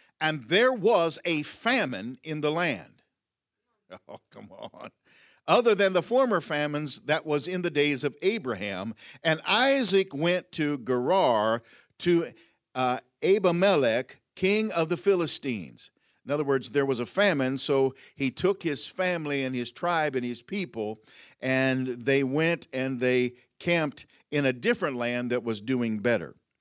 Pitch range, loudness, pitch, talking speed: 130-175 Hz, -26 LUFS, 145 Hz, 150 wpm